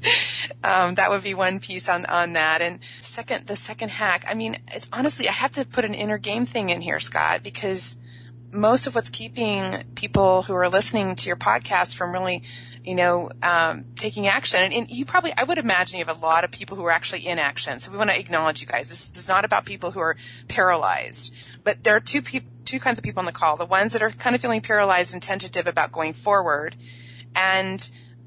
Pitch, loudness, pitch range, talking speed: 175 Hz, -22 LUFS, 125-200 Hz, 225 wpm